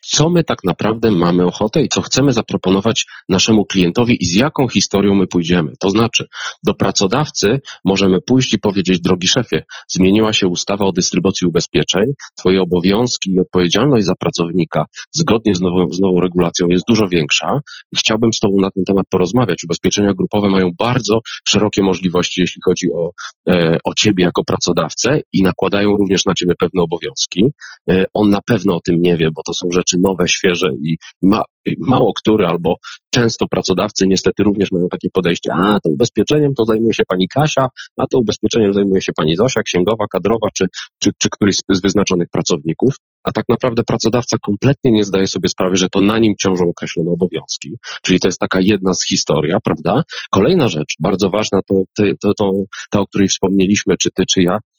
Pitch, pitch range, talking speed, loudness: 95 Hz, 90-105 Hz, 185 wpm, -15 LUFS